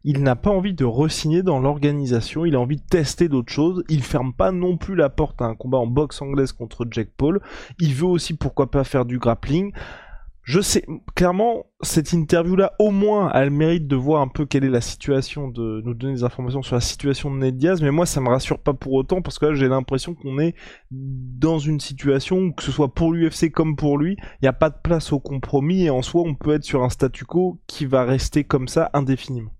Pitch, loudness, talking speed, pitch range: 145 Hz, -21 LUFS, 245 wpm, 130-165 Hz